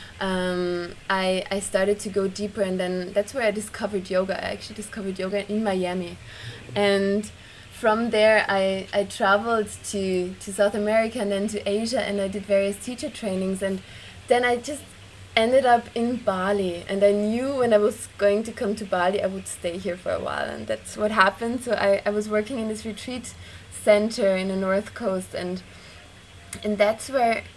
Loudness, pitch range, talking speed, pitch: -24 LUFS, 190-215 Hz, 190 wpm, 200 Hz